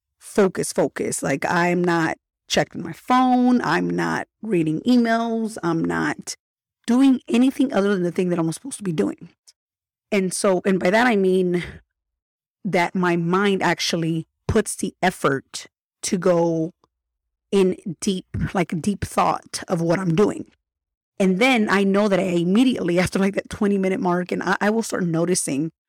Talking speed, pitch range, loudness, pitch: 160 wpm, 175-215 Hz, -21 LUFS, 190 Hz